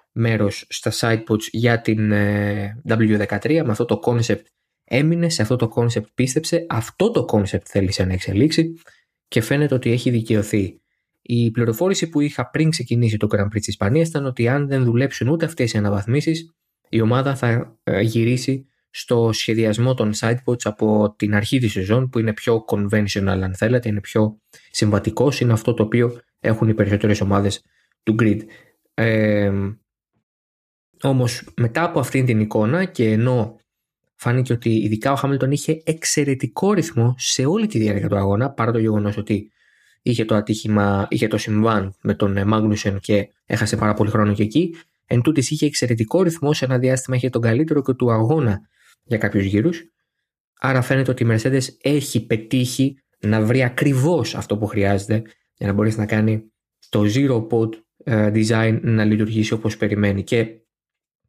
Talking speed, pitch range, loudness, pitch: 160 wpm, 105-130 Hz, -20 LUFS, 115 Hz